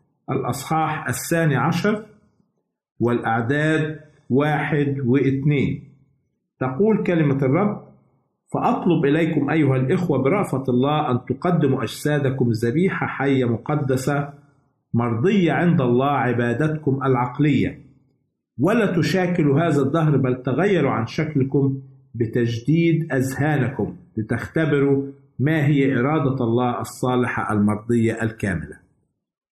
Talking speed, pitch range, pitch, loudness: 90 wpm, 125-155 Hz, 140 Hz, -21 LUFS